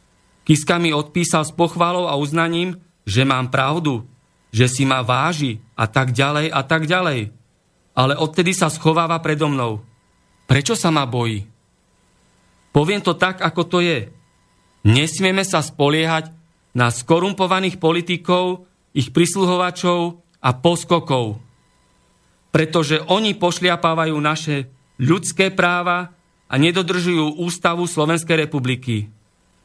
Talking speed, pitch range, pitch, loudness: 115 wpm, 130-175 Hz, 160 Hz, -18 LUFS